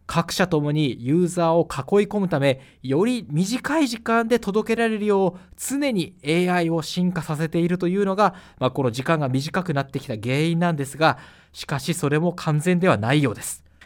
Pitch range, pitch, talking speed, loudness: 145-190 Hz, 165 Hz, 365 characters per minute, -22 LUFS